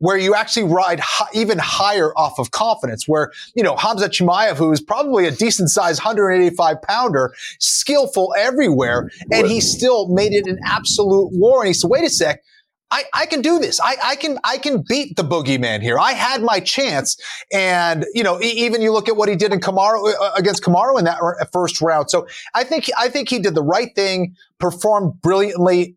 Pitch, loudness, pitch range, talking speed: 200 Hz, -17 LUFS, 175-225 Hz, 205 wpm